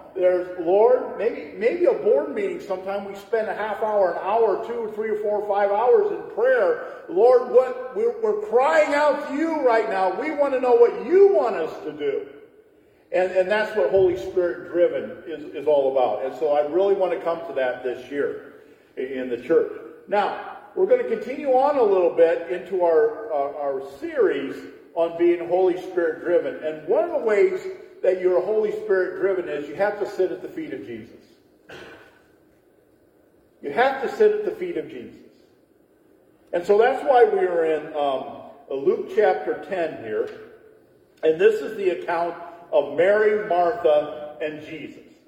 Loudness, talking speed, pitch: -22 LUFS, 185 wpm, 225 Hz